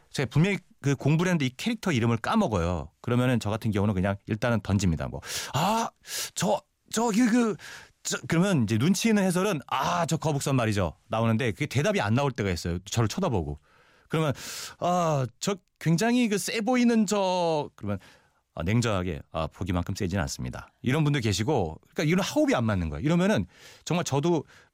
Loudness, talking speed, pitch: -27 LUFS, 375 characters per minute, 130 Hz